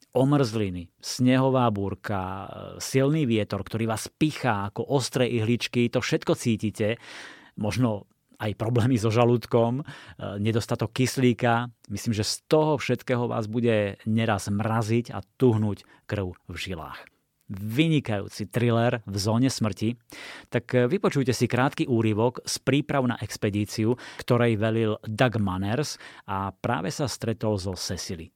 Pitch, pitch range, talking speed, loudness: 115 Hz, 105-125 Hz, 125 wpm, -26 LUFS